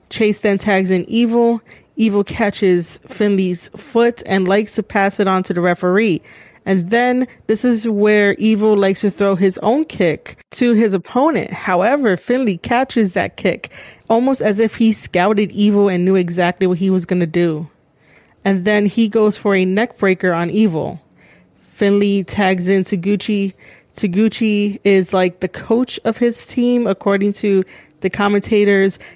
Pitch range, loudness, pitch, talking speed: 190-225 Hz, -16 LUFS, 205 Hz, 160 wpm